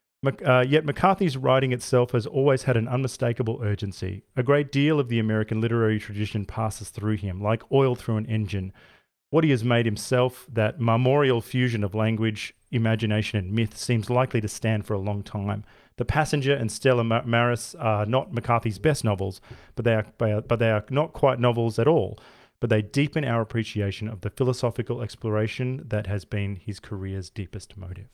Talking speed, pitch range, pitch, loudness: 180 wpm, 105-125 Hz, 115 Hz, -25 LUFS